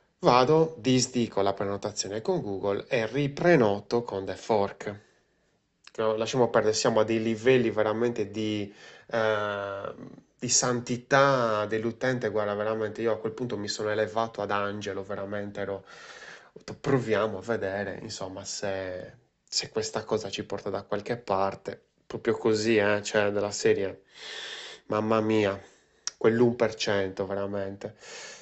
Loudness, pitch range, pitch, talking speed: -28 LUFS, 100-120 Hz, 110 Hz, 125 wpm